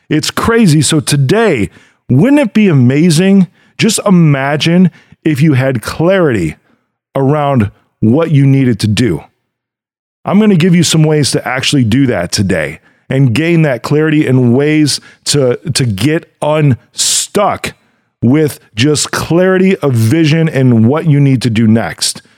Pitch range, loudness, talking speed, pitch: 130-160 Hz, -10 LUFS, 145 wpm, 145 Hz